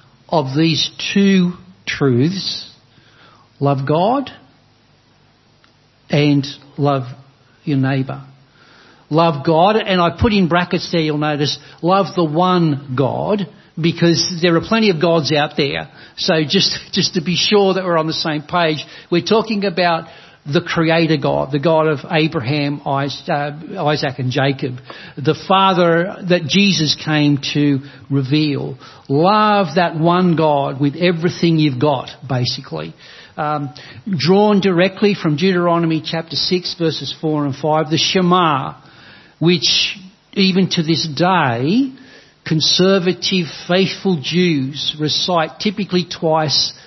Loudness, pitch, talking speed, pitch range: -16 LUFS, 160 Hz, 125 wpm, 145-180 Hz